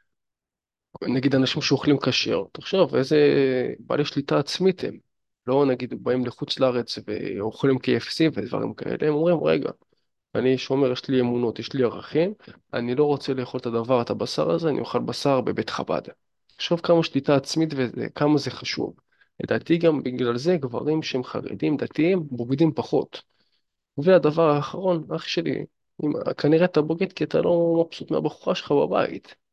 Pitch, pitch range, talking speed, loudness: 140 Hz, 130-160 Hz, 160 wpm, -24 LUFS